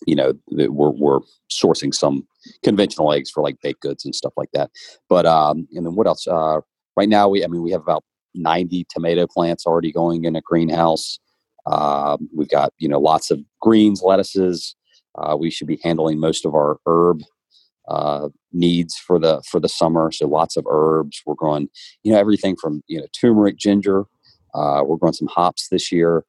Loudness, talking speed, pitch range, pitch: -19 LUFS, 195 wpm, 80-90 Hz, 85 Hz